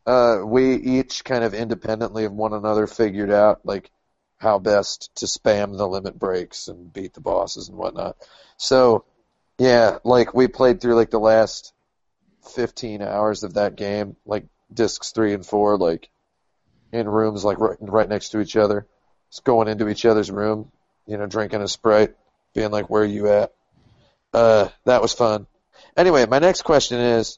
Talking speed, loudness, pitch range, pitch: 175 wpm, -20 LUFS, 105-115 Hz, 110 Hz